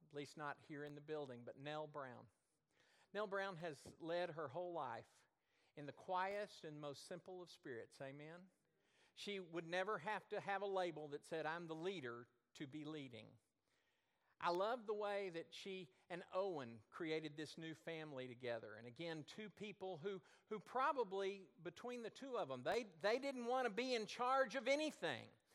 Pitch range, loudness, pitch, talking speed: 150-200 Hz, -47 LUFS, 175 Hz, 180 wpm